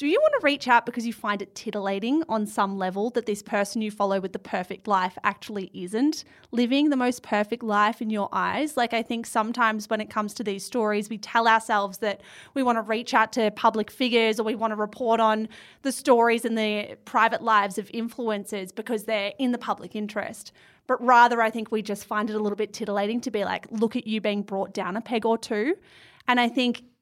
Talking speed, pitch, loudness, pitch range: 230 wpm, 220 Hz, -25 LUFS, 210-240 Hz